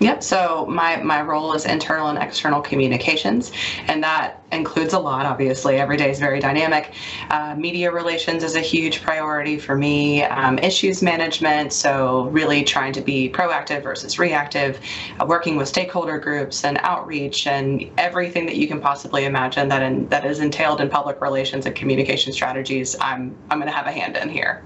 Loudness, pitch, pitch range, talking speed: -20 LUFS, 145 Hz, 135-160 Hz, 185 wpm